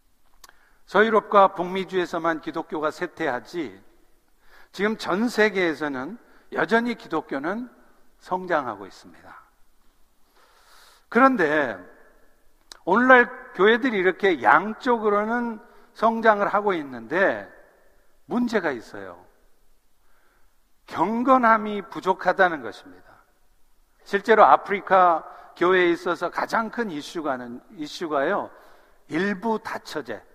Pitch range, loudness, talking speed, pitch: 180-235 Hz, -22 LUFS, 225 characters per minute, 210 Hz